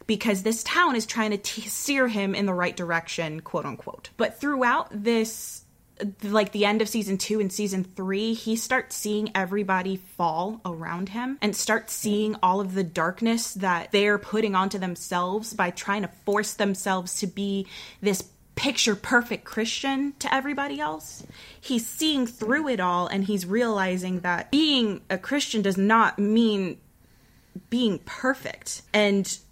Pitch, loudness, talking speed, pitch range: 210 Hz, -25 LUFS, 155 wpm, 190-225 Hz